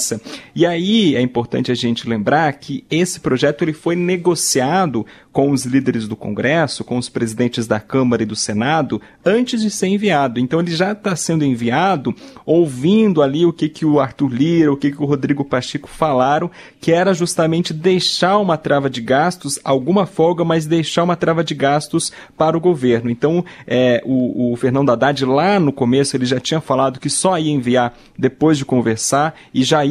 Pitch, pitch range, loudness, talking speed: 145 Hz, 130-170 Hz, -17 LUFS, 185 wpm